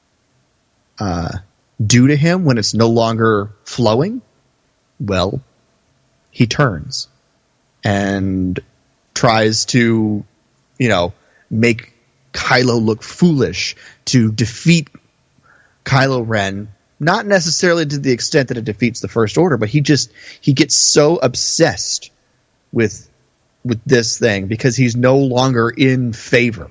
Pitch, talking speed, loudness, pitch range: 120 Hz, 120 wpm, -15 LUFS, 110-135 Hz